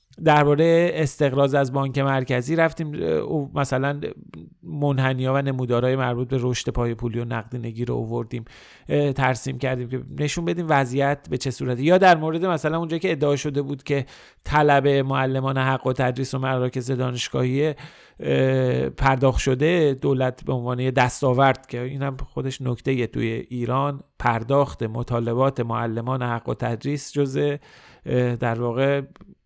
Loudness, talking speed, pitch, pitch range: -22 LUFS, 145 wpm, 135 Hz, 125-145 Hz